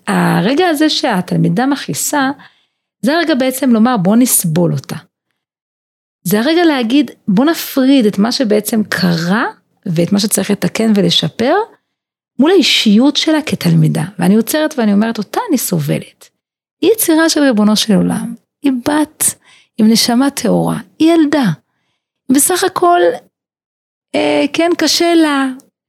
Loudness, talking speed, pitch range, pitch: -12 LUFS, 125 wpm, 200-305 Hz, 250 Hz